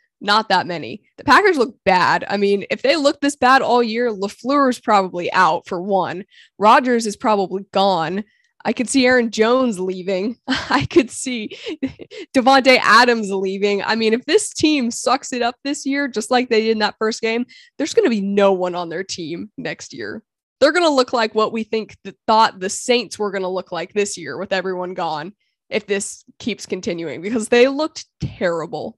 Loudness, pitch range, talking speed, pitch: -18 LUFS, 195-260 Hz, 200 wpm, 225 Hz